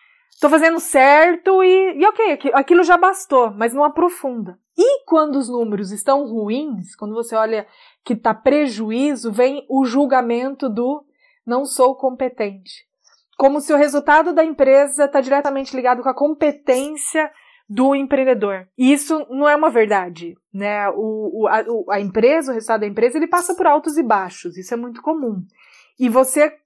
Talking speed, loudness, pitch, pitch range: 165 wpm, -17 LUFS, 270 Hz, 230-300 Hz